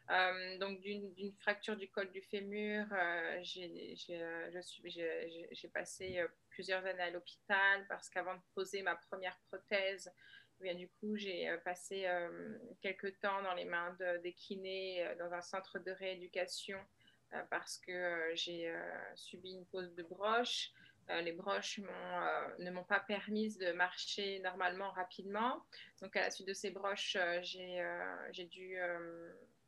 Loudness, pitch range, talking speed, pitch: -41 LUFS, 180-200 Hz, 170 wpm, 185 Hz